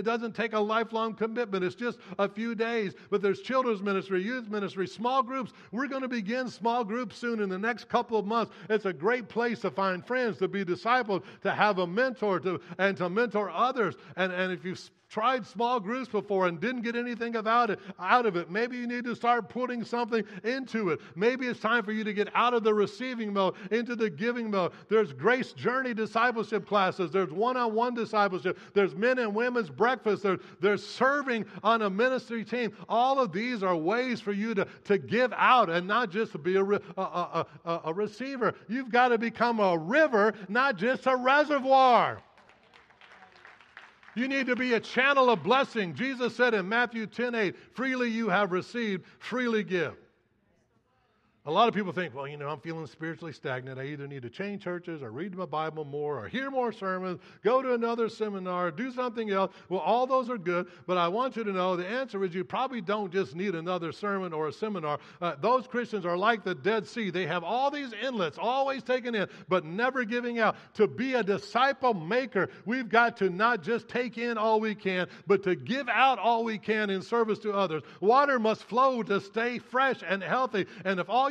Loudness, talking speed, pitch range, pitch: -29 LUFS, 205 wpm, 190-240 Hz, 215 Hz